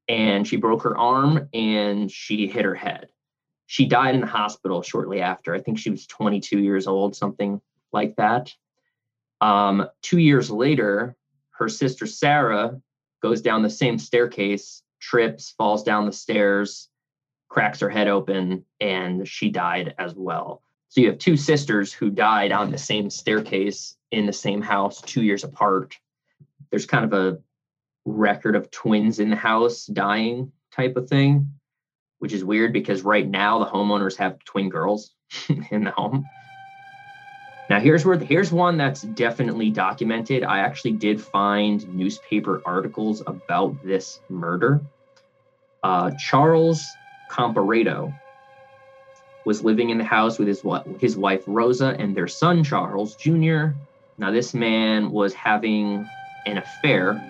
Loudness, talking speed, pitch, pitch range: -22 LUFS, 150 wpm, 115 Hz, 105-145 Hz